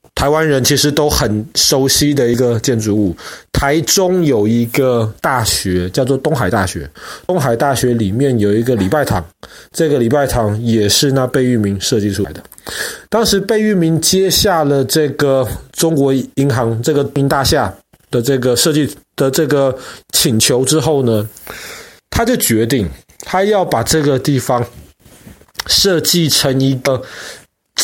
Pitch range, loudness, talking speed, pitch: 115-150 Hz, -14 LUFS, 225 characters per minute, 135 Hz